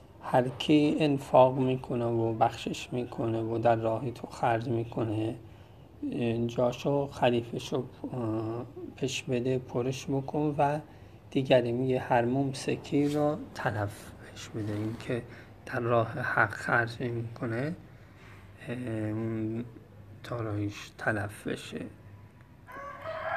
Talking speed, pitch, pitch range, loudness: 100 wpm, 120 Hz, 110-130 Hz, -30 LUFS